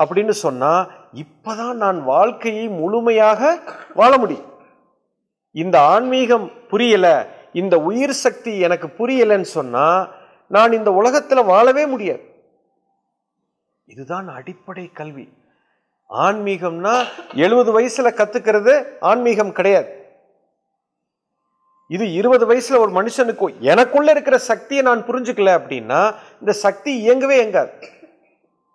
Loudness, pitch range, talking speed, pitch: -16 LUFS, 200-255 Hz, 95 wpm, 230 Hz